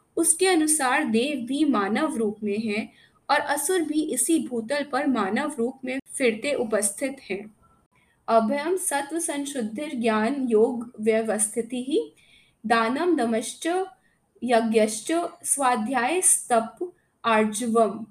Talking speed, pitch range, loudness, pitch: 115 wpm, 225-300 Hz, -24 LUFS, 250 Hz